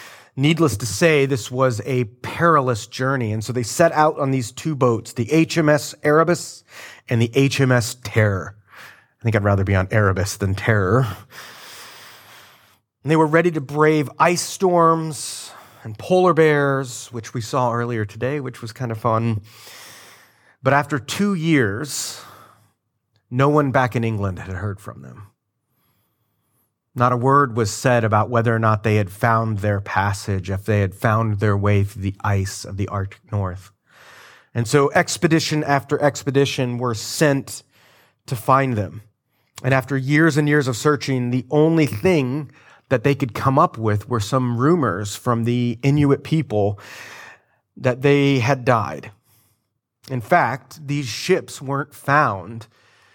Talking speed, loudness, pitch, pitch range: 155 wpm, -19 LUFS, 125 Hz, 110-140 Hz